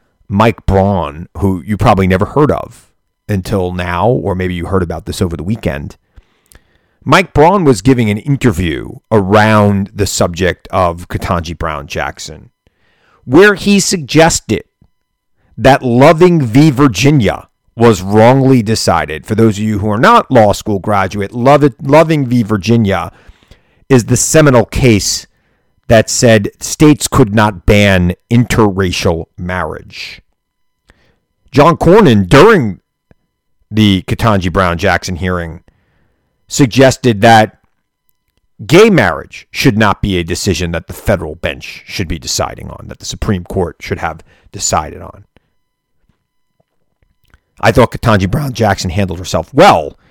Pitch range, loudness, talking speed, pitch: 90-120 Hz, -11 LUFS, 130 wpm, 105 Hz